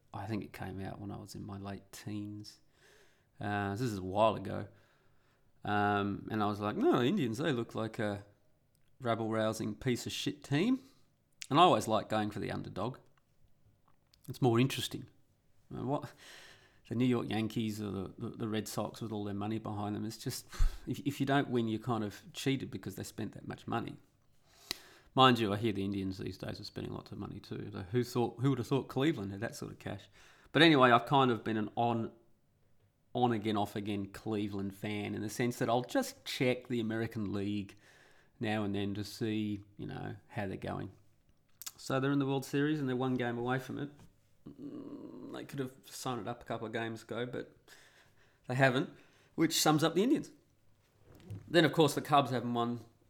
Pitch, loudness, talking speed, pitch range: 115 Hz, -34 LUFS, 200 wpm, 105-130 Hz